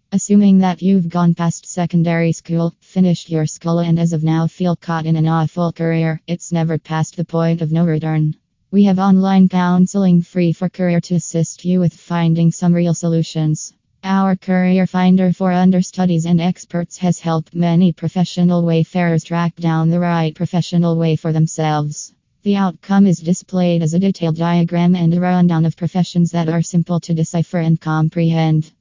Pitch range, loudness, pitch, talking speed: 165-180 Hz, -16 LUFS, 170 Hz, 175 wpm